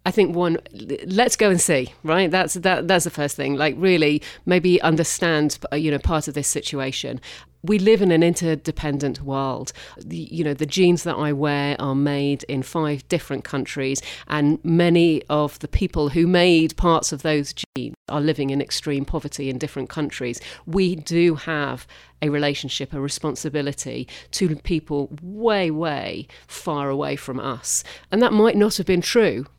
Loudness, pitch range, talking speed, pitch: -21 LUFS, 140-175 Hz, 170 wpm, 150 Hz